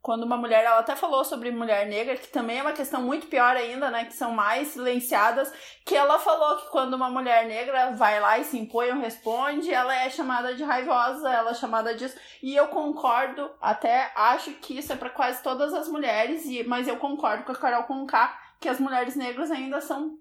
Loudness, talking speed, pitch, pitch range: -25 LUFS, 215 wpm, 260 Hz, 240-290 Hz